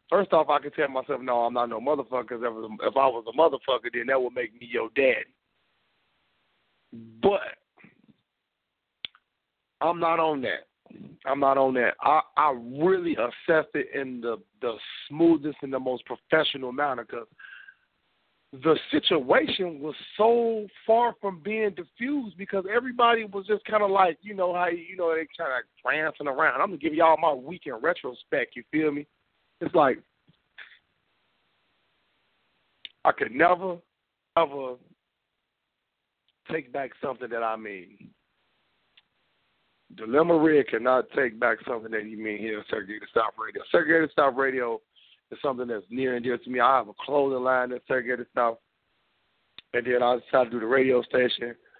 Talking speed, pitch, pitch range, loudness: 160 wpm, 145 Hz, 125-180 Hz, -26 LUFS